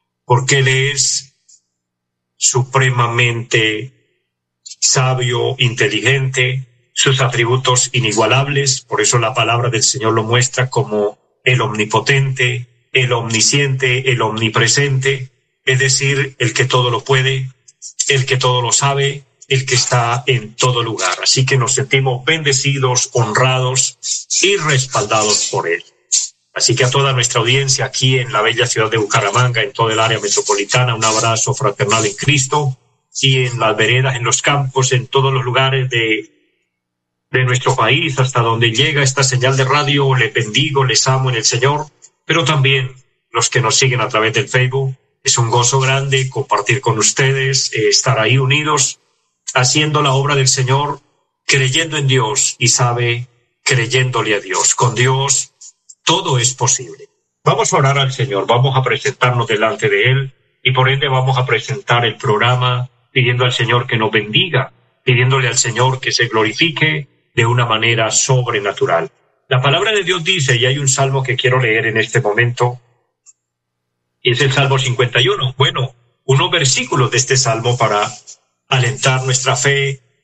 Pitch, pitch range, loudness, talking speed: 130 Hz, 120-135 Hz, -14 LUFS, 155 wpm